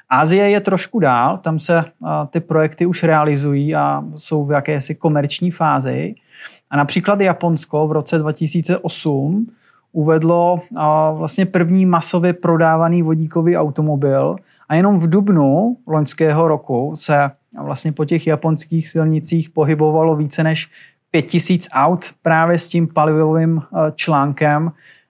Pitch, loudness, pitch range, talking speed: 160 Hz, -16 LUFS, 150-170 Hz, 120 wpm